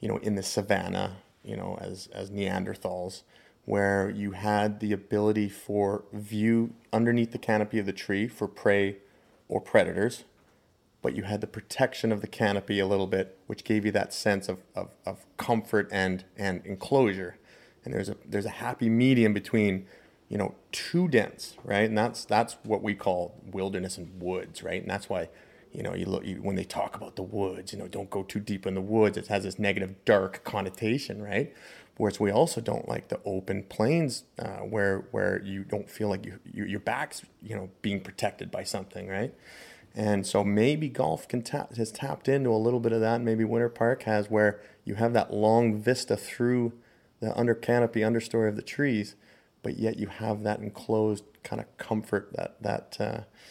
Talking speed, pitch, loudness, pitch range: 195 wpm, 105 Hz, -29 LUFS, 100-115 Hz